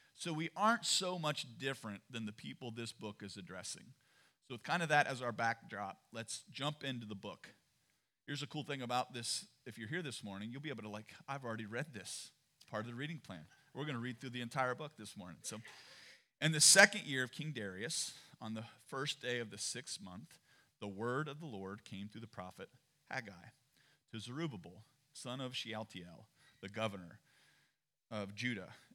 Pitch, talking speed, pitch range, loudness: 125 Hz, 200 wpm, 110-145 Hz, -38 LUFS